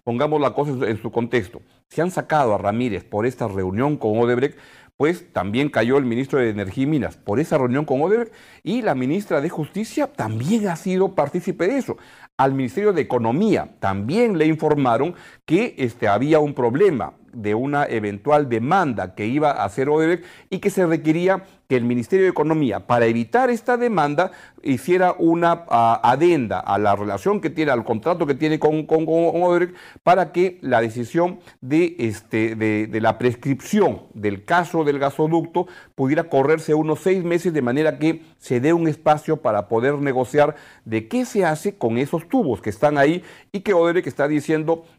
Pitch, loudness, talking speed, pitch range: 150 Hz, -20 LUFS, 185 wpm, 120-175 Hz